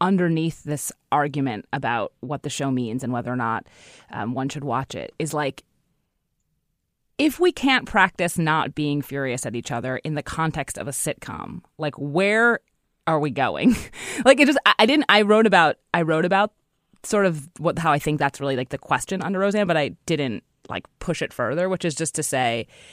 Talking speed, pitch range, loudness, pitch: 200 wpm, 135-195 Hz, -22 LUFS, 155 Hz